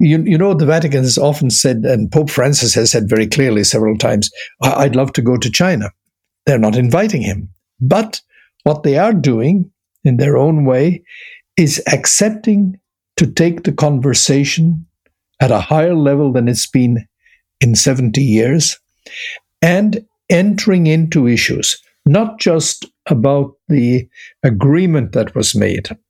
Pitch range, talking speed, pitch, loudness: 125-170 Hz, 145 wpm, 145 Hz, -13 LUFS